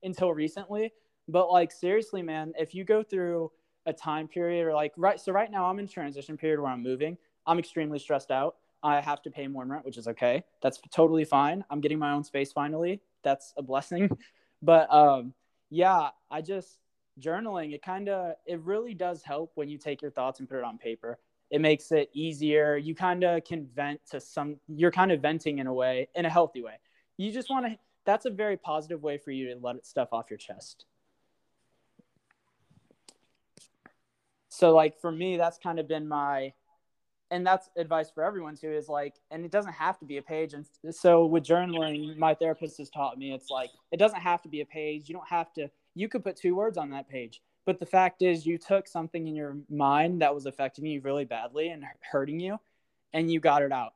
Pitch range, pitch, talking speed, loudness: 145-175 Hz, 160 Hz, 210 wpm, -29 LUFS